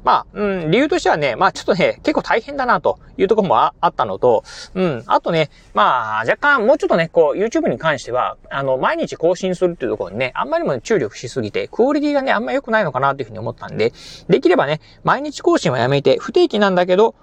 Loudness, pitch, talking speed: -17 LUFS, 220 Hz, 500 characters per minute